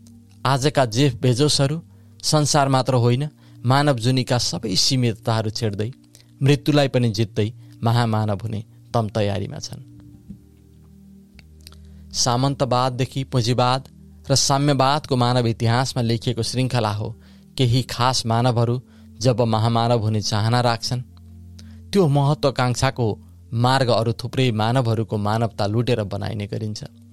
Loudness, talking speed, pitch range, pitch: -21 LUFS, 100 wpm, 110-130 Hz, 120 Hz